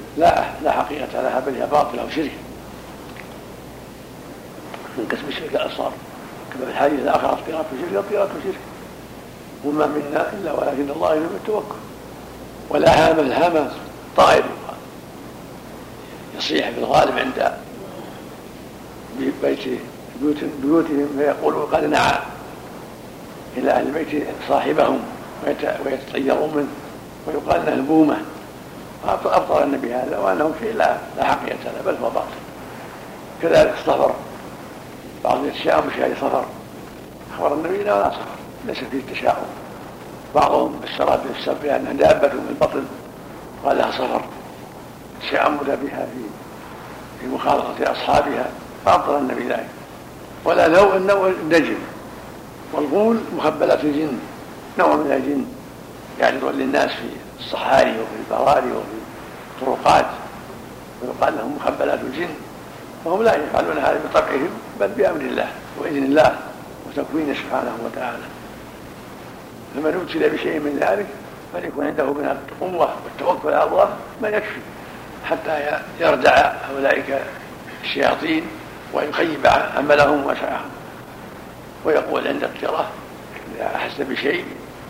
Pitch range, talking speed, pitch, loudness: 145-200 Hz, 115 wpm, 155 Hz, -20 LUFS